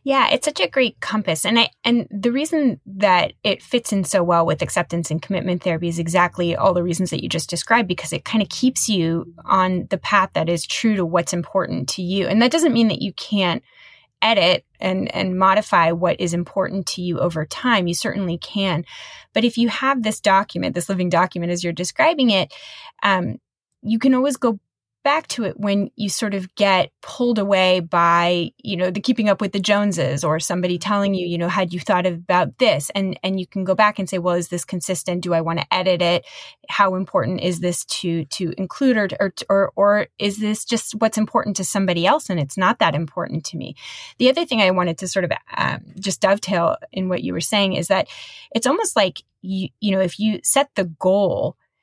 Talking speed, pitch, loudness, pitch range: 220 wpm, 190 Hz, -20 LUFS, 175-215 Hz